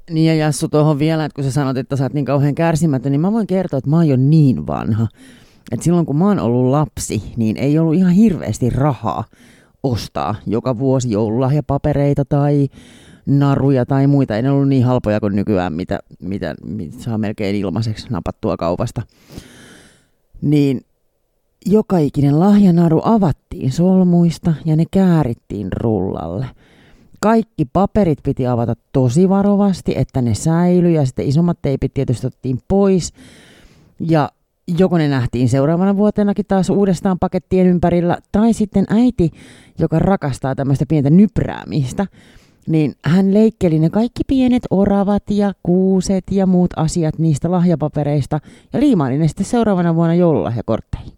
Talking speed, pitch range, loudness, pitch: 150 wpm, 130-185 Hz, -16 LUFS, 150 Hz